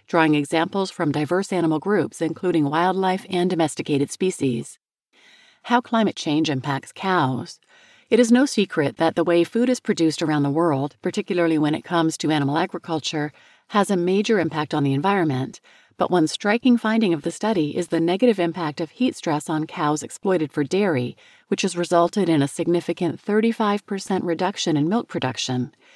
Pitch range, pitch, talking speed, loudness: 155-195 Hz, 170 Hz, 170 wpm, -22 LUFS